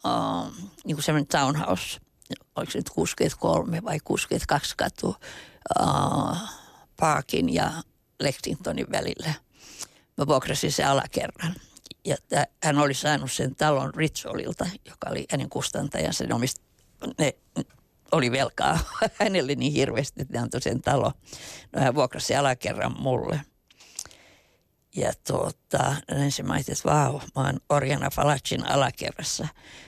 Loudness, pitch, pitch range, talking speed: -26 LUFS, 145 Hz, 140-155 Hz, 125 wpm